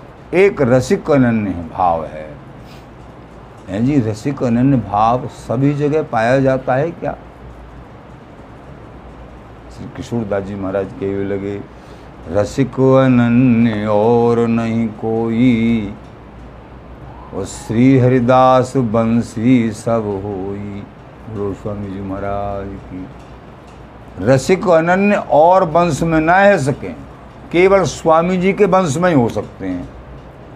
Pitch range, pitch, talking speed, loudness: 100-140 Hz, 120 Hz, 105 wpm, -15 LUFS